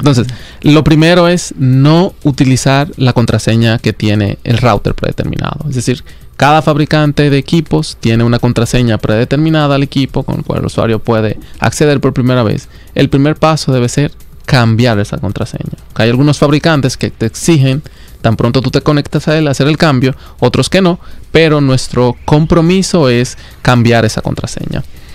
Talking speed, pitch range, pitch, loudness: 165 wpm, 120-155 Hz, 135 Hz, -11 LUFS